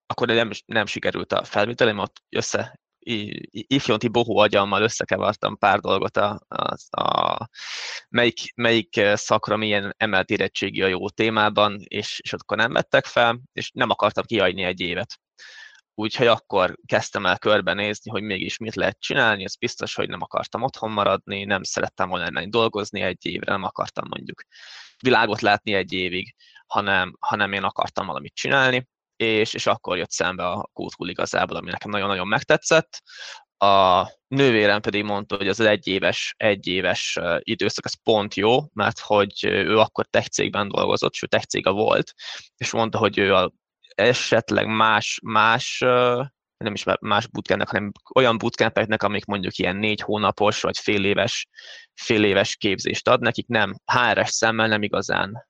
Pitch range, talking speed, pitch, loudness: 100-115 Hz, 150 wpm, 105 Hz, -22 LUFS